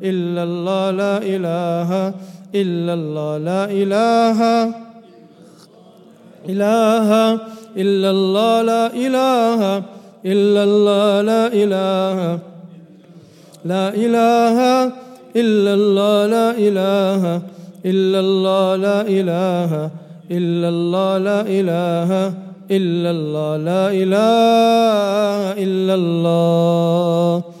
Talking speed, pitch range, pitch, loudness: 80 wpm, 175-210 Hz, 195 Hz, -16 LUFS